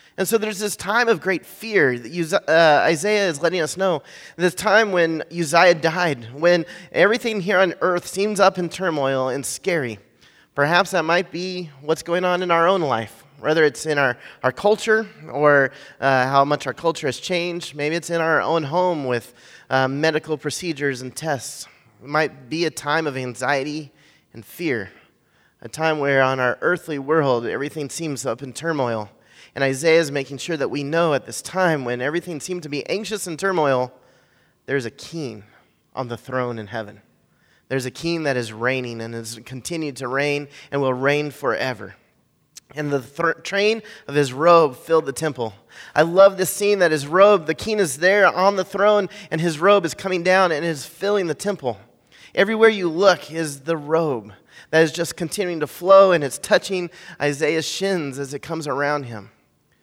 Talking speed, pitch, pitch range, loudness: 190 wpm, 160 Hz, 140-180 Hz, -20 LUFS